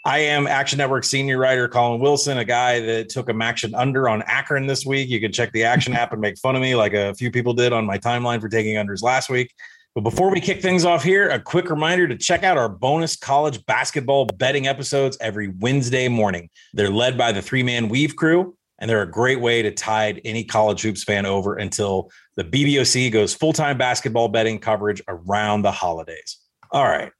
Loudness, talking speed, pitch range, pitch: -20 LUFS, 220 wpm, 110-140 Hz, 125 Hz